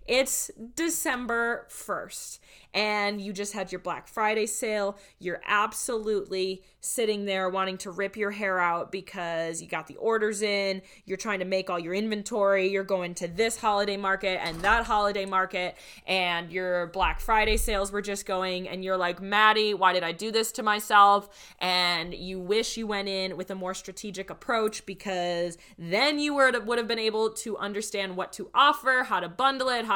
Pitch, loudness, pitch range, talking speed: 200 Hz, -27 LUFS, 185-220 Hz, 180 wpm